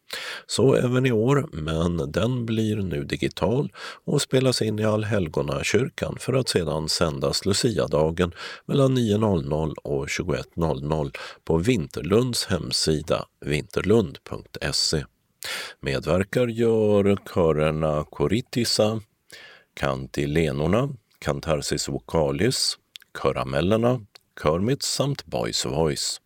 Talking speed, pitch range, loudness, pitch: 90 wpm, 80-120 Hz, -24 LUFS, 105 Hz